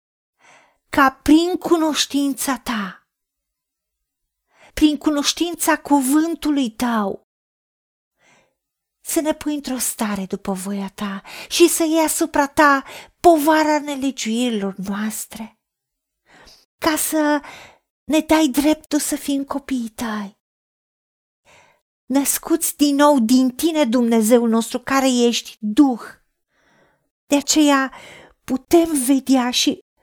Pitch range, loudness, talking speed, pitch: 240-305 Hz, -18 LUFS, 95 wpm, 280 Hz